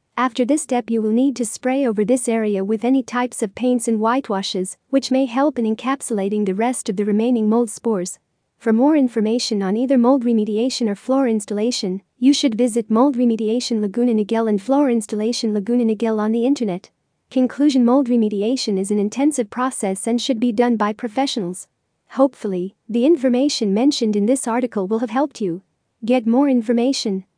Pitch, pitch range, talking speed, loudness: 235 Hz, 215-255 Hz, 180 wpm, -19 LUFS